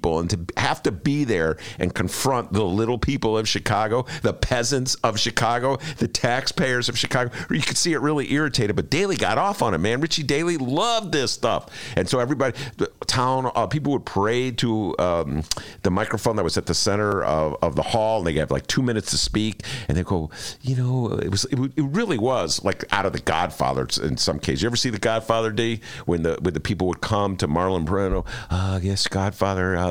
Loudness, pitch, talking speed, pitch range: -23 LUFS, 115 Hz, 220 wpm, 95-130 Hz